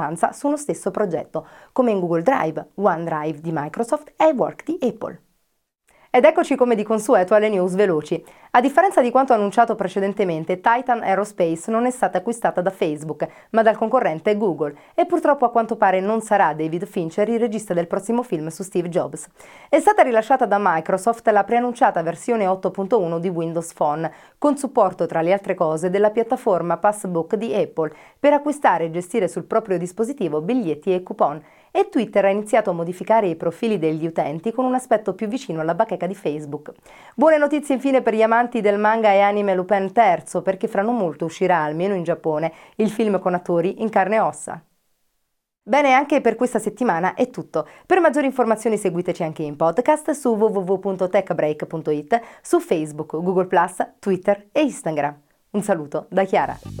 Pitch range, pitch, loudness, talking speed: 170-235 Hz, 200 Hz, -20 LUFS, 170 wpm